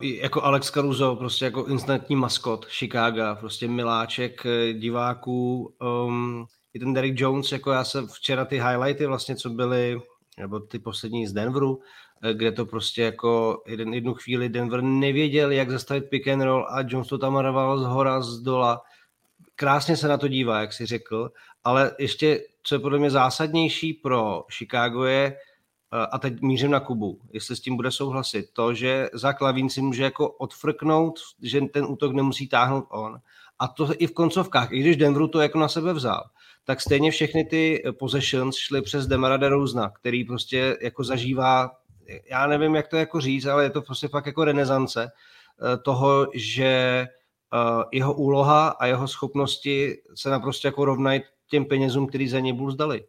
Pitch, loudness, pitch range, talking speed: 130 Hz, -24 LUFS, 120-140 Hz, 170 wpm